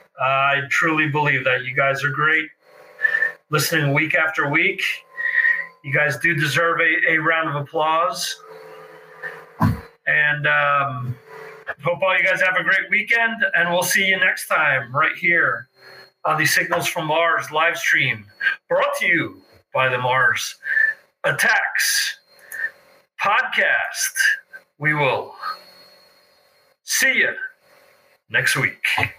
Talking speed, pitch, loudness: 125 wpm, 175 Hz, -19 LUFS